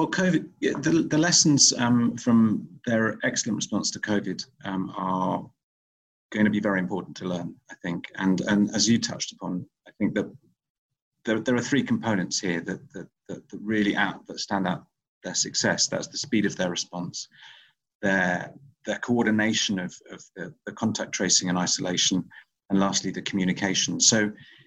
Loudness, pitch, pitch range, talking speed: -25 LUFS, 105 Hz, 95-120 Hz, 170 wpm